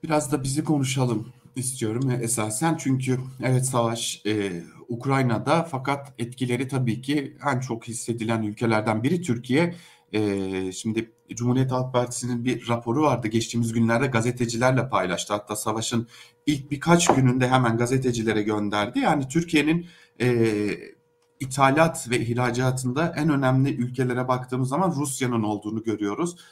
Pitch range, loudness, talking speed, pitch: 115-140 Hz, -24 LUFS, 125 wpm, 125 Hz